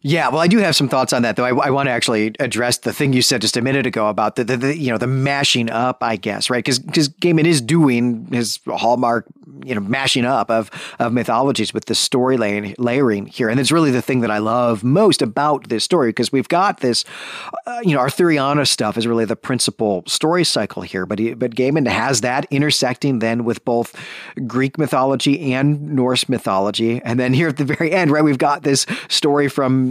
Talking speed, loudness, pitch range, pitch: 220 wpm, -17 LUFS, 115-145 Hz, 130 Hz